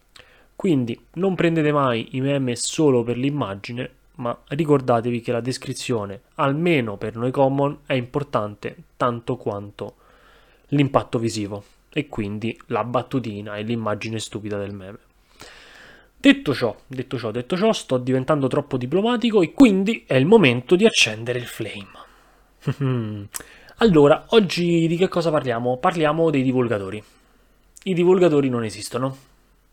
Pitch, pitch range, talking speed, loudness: 130 Hz, 115-155 Hz, 130 wpm, -21 LUFS